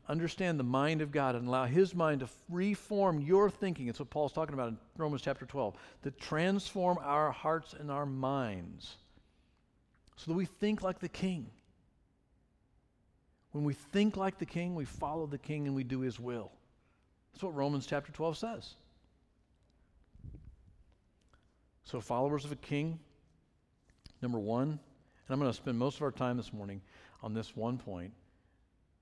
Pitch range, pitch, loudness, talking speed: 115-160 Hz, 140 Hz, -36 LUFS, 165 wpm